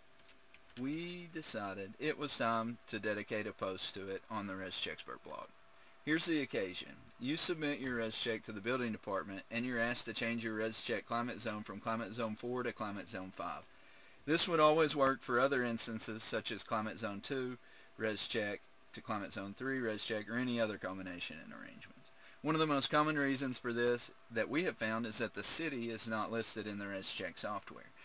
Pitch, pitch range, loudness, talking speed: 115 Hz, 110-130 Hz, -38 LUFS, 195 wpm